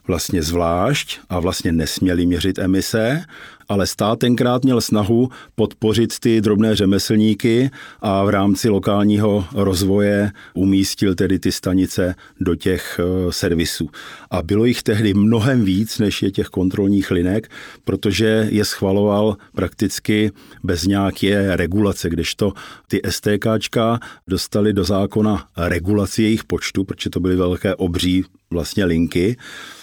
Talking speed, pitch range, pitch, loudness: 125 wpm, 95-110 Hz, 100 Hz, -18 LUFS